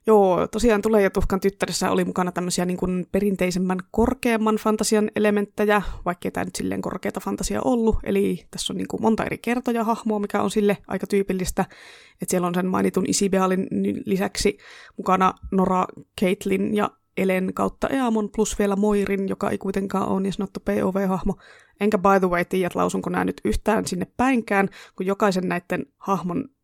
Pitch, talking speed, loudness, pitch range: 195 Hz, 170 wpm, -23 LUFS, 185-210 Hz